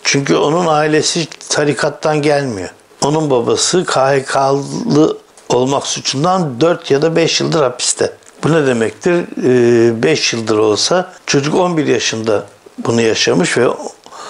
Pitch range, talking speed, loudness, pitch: 135-170 Hz, 115 wpm, -14 LUFS, 150 Hz